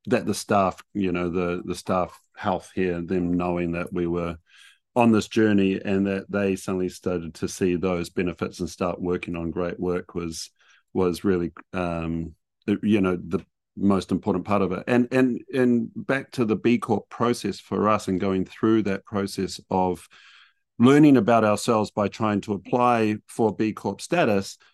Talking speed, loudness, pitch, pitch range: 175 wpm, -24 LUFS, 95 Hz, 90-105 Hz